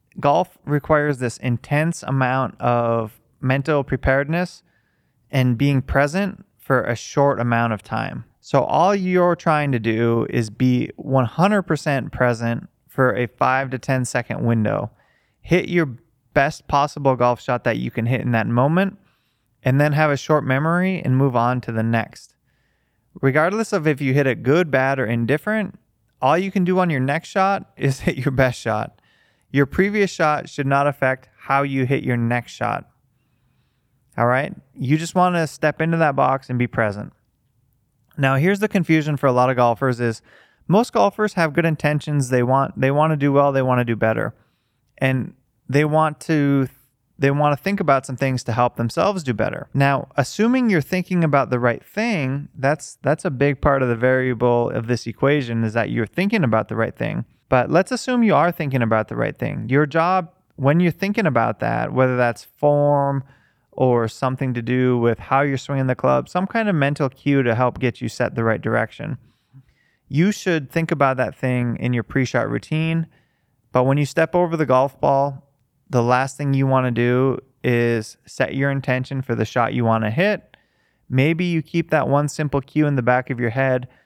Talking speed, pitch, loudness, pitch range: 195 wpm, 135 Hz, -20 LUFS, 125-155 Hz